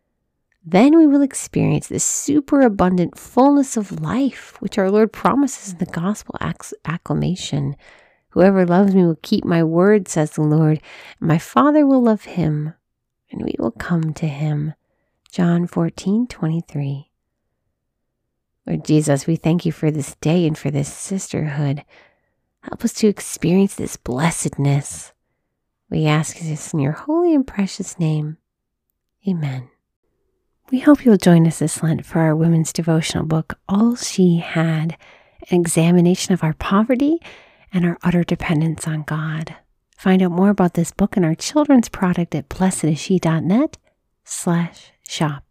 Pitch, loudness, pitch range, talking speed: 175 Hz, -18 LUFS, 155-200 Hz, 150 wpm